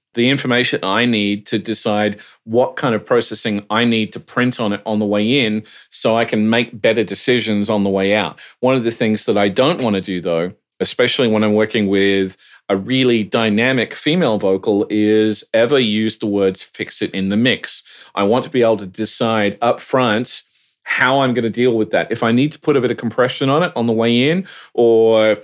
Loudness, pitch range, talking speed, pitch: -16 LUFS, 105-120 Hz, 220 wpm, 110 Hz